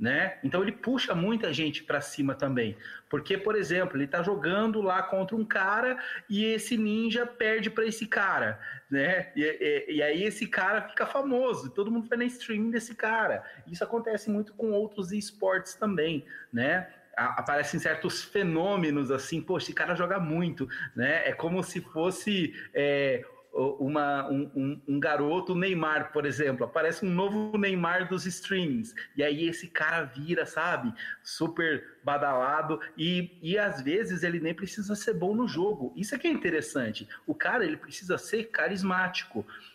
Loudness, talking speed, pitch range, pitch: -29 LUFS, 165 wpm, 155-220 Hz, 185 Hz